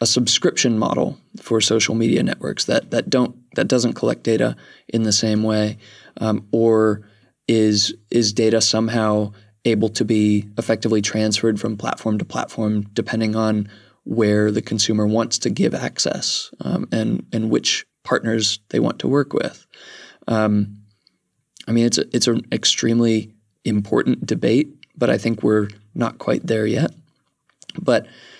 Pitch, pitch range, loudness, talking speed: 110 Hz, 105-115 Hz, -19 LUFS, 150 wpm